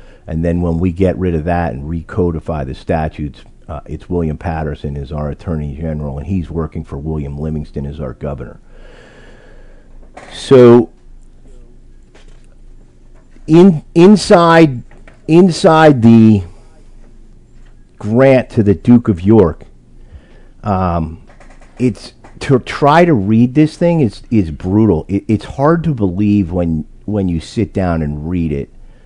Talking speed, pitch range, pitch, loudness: 130 wpm, 80-120 Hz, 95 Hz, -13 LUFS